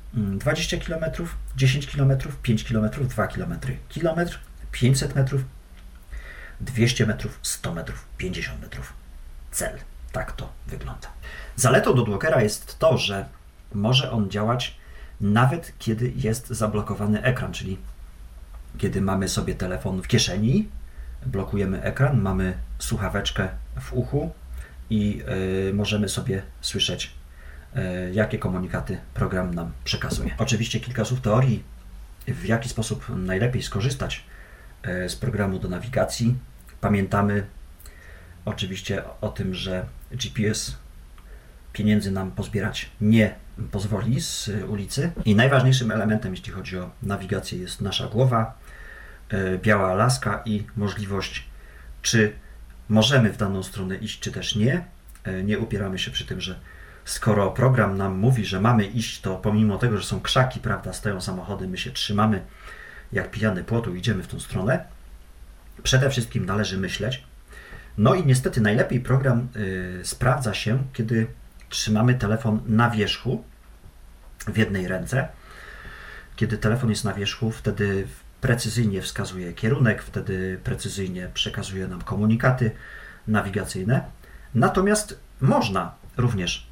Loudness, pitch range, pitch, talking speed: -24 LUFS, 95-120 Hz, 105 Hz, 120 wpm